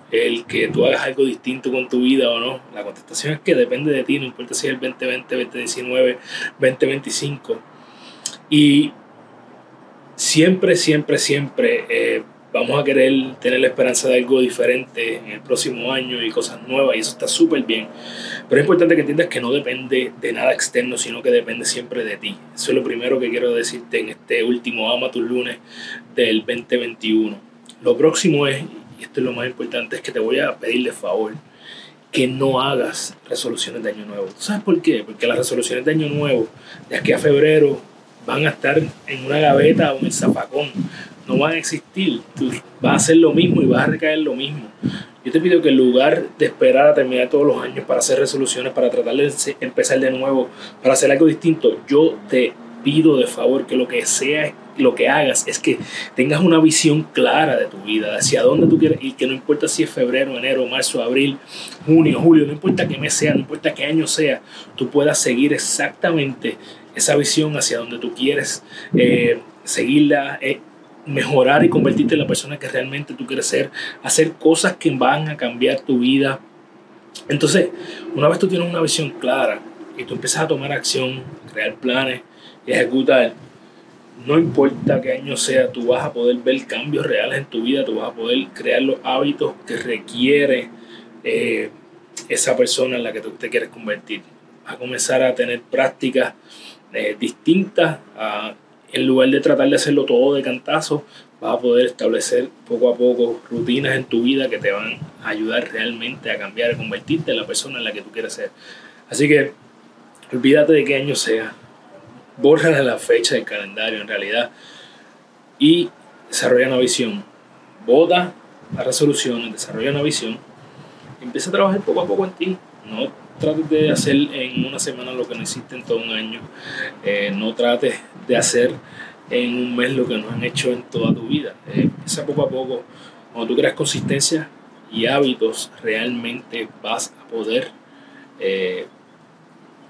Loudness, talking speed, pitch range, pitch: -18 LUFS, 185 wpm, 125-175 Hz, 145 Hz